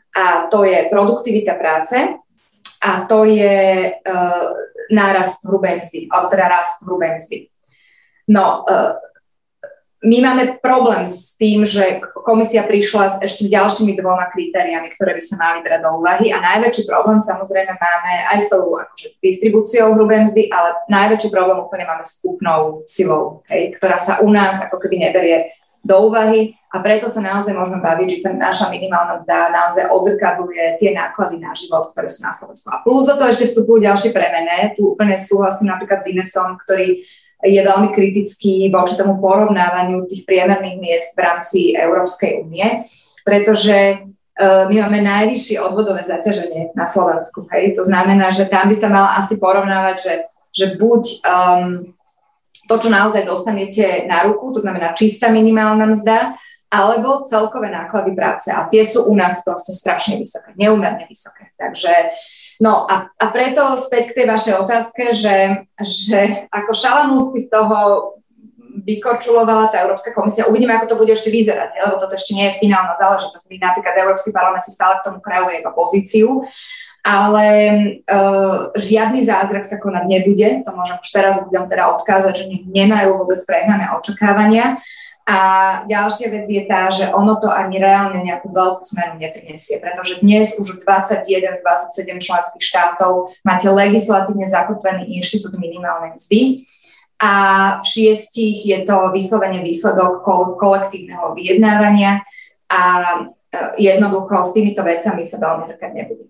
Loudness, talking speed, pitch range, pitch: -14 LUFS, 155 wpm, 185-220 Hz, 195 Hz